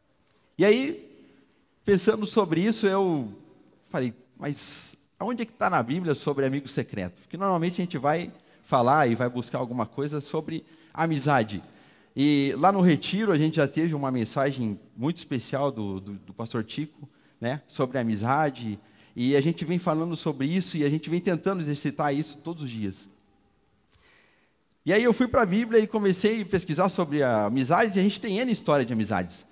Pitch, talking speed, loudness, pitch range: 145 Hz, 180 wpm, -26 LUFS, 125-180 Hz